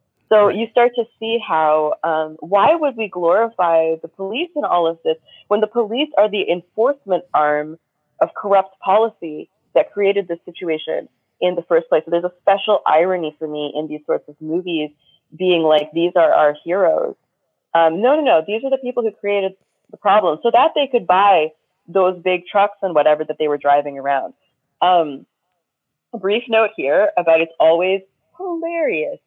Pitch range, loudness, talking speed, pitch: 160-220 Hz, -17 LUFS, 185 wpm, 180 Hz